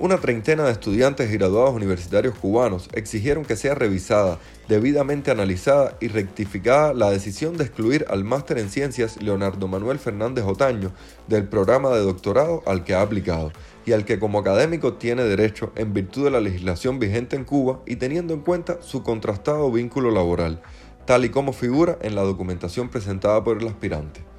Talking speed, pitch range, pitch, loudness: 170 wpm, 100-130 Hz, 110 Hz, -22 LUFS